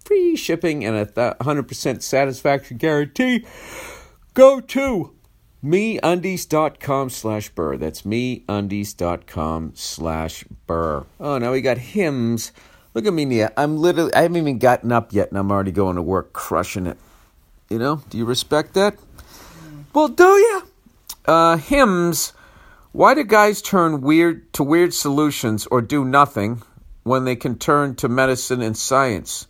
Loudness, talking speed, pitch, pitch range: -19 LUFS, 150 wpm, 135 Hz, 110-165 Hz